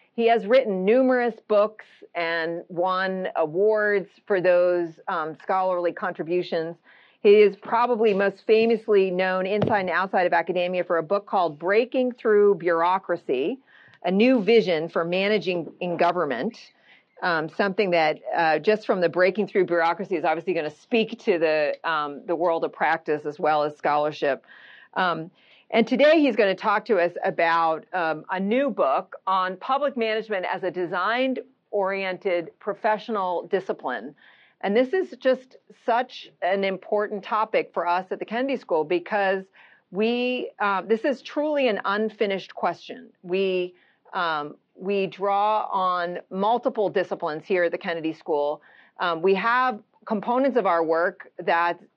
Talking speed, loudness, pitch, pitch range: 150 wpm, -24 LUFS, 195 Hz, 175-225 Hz